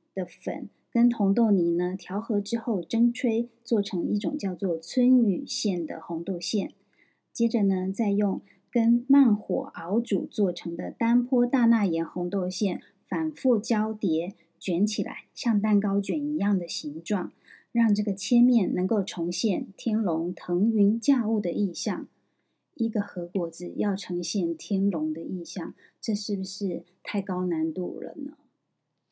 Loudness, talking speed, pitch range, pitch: -27 LUFS, 215 characters per minute, 180-230 Hz, 205 Hz